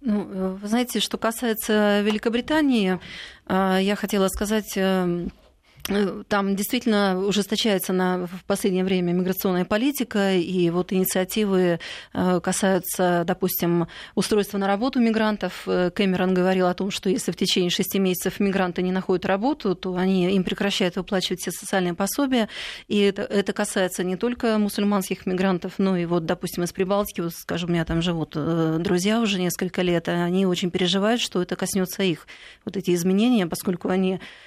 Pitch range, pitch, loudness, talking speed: 180-205 Hz, 190 Hz, -23 LUFS, 150 wpm